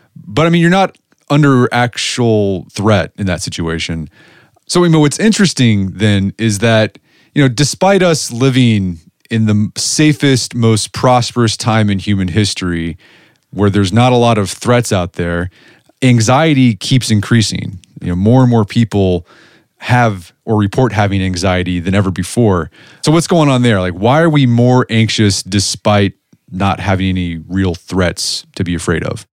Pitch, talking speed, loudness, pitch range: 110 Hz, 165 wpm, -13 LUFS, 95-130 Hz